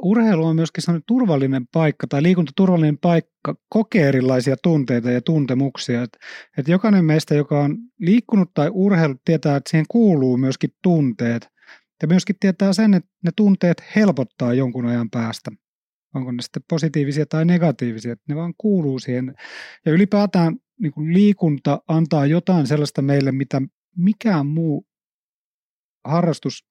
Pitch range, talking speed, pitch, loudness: 135-180 Hz, 145 wpm, 160 Hz, -19 LUFS